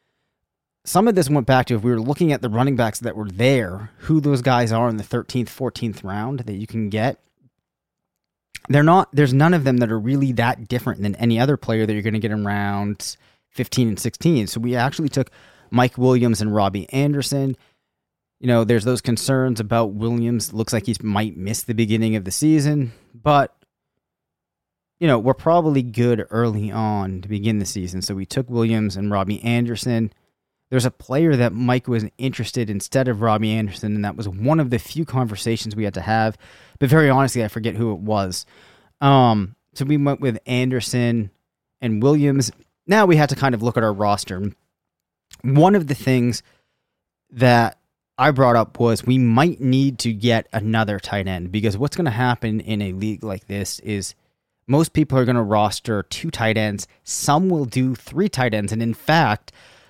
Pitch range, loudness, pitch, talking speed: 105-130 Hz, -20 LUFS, 120 Hz, 195 wpm